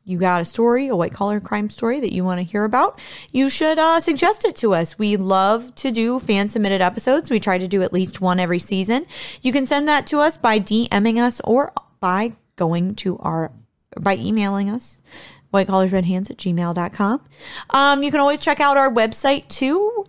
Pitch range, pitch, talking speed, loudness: 190-275 Hz, 220 Hz, 200 wpm, -19 LUFS